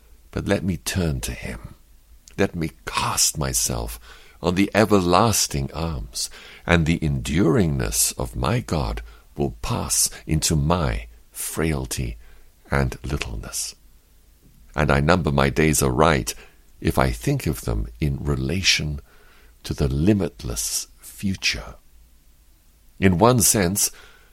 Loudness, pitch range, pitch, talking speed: -22 LUFS, 70-85 Hz, 75 Hz, 115 wpm